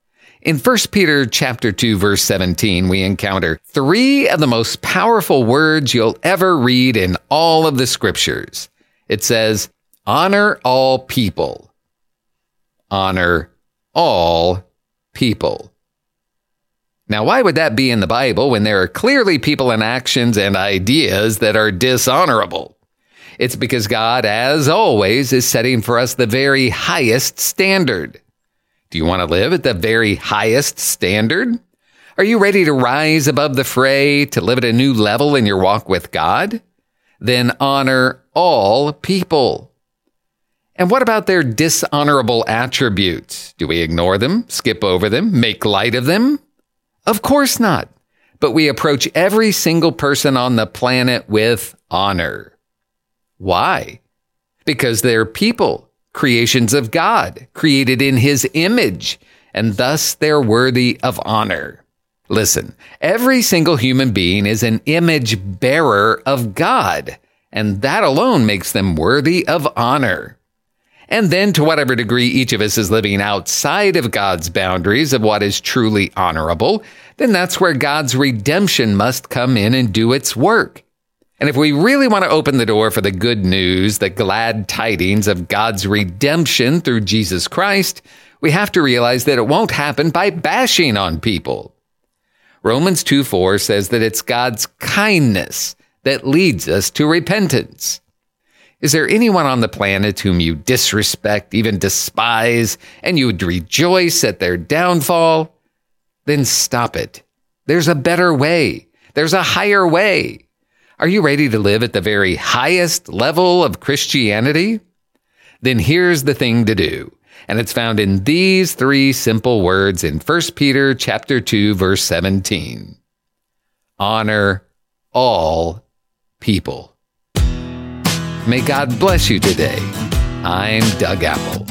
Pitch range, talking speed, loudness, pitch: 105-155 Hz, 140 wpm, -14 LUFS, 125 Hz